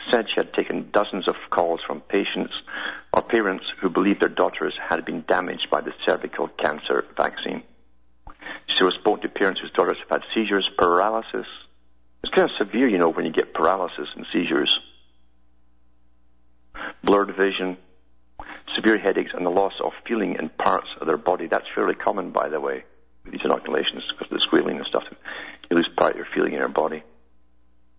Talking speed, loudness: 180 wpm, -23 LUFS